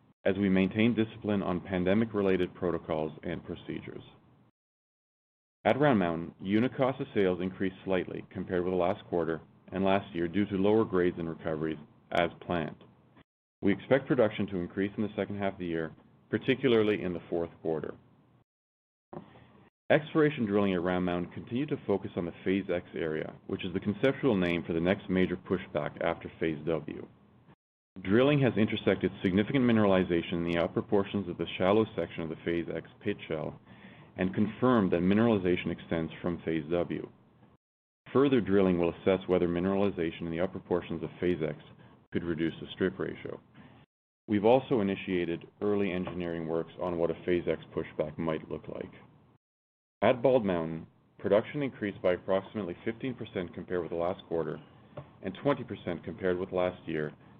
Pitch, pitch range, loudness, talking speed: 95 Hz, 85-105 Hz, -31 LUFS, 165 wpm